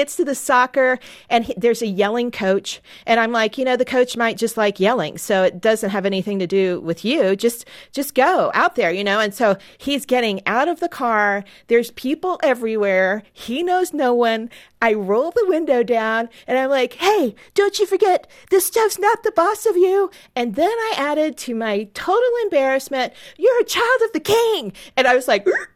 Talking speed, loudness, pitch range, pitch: 205 wpm, -19 LUFS, 225-345 Hz, 255 Hz